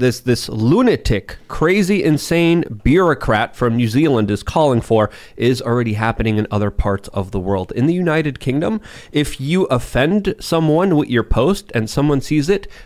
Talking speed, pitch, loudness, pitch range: 170 wpm, 130 Hz, -17 LUFS, 110-160 Hz